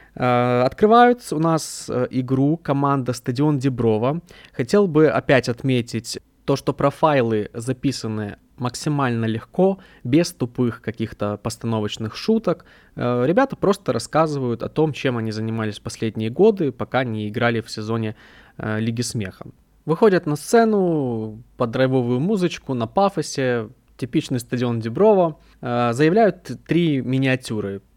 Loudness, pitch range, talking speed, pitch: -21 LUFS, 115-155 Hz, 115 wpm, 130 Hz